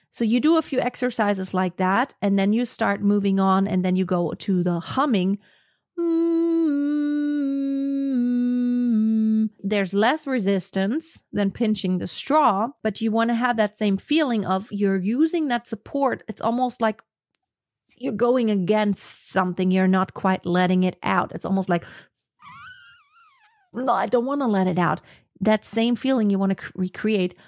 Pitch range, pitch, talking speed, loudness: 195-255 Hz, 220 Hz, 160 wpm, -22 LUFS